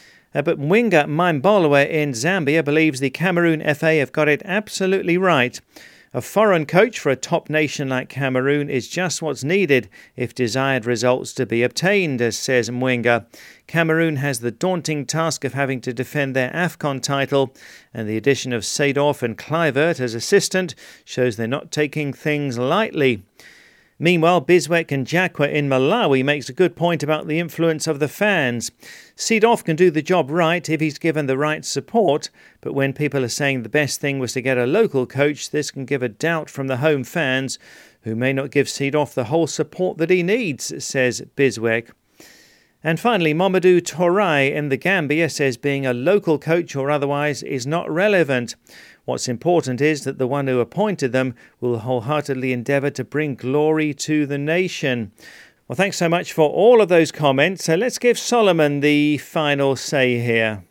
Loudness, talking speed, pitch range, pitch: -19 LUFS, 175 wpm, 130-165 Hz, 145 Hz